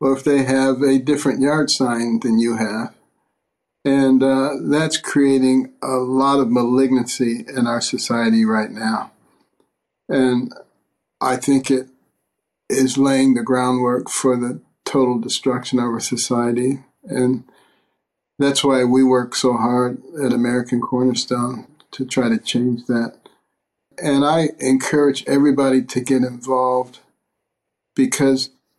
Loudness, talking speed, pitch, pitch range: -18 LUFS, 130 wpm, 130 Hz, 125-135 Hz